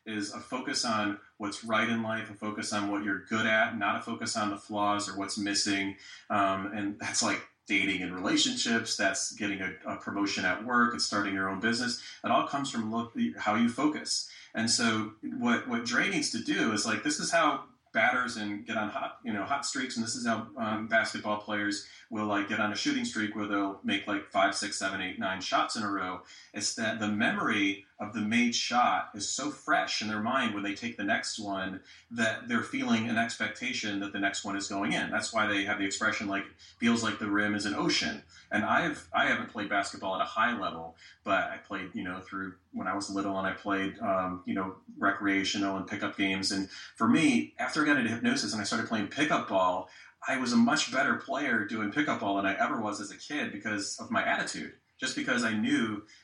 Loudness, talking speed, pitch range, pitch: -30 LUFS, 230 wpm, 100-115 Hz, 105 Hz